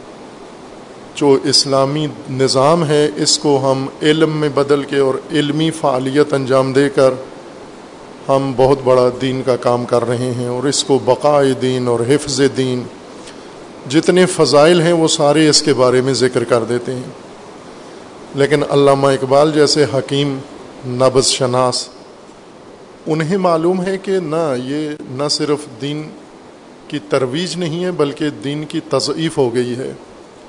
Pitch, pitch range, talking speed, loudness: 140 Hz, 130-150 Hz, 145 wpm, -15 LUFS